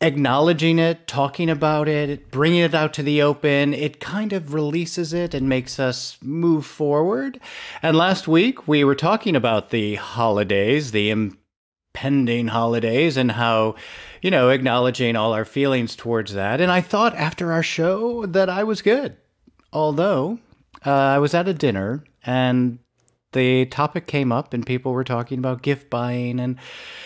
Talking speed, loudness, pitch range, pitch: 160 wpm, -20 LUFS, 125-165 Hz, 140 Hz